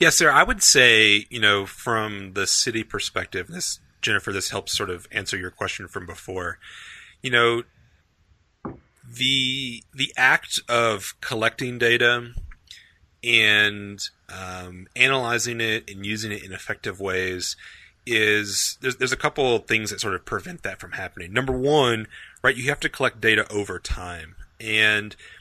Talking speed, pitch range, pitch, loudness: 155 wpm, 95-120 Hz, 110 Hz, -21 LUFS